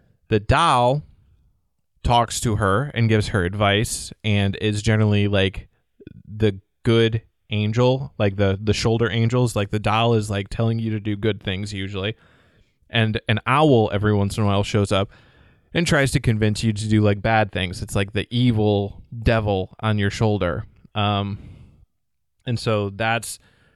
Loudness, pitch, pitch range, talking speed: -21 LUFS, 110 Hz, 100-115 Hz, 165 wpm